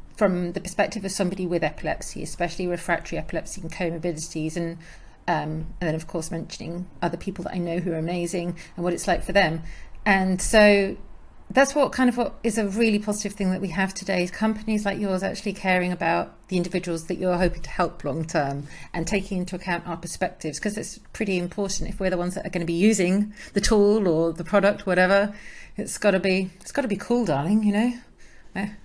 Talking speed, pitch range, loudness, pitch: 215 wpm, 175-205 Hz, -25 LUFS, 185 Hz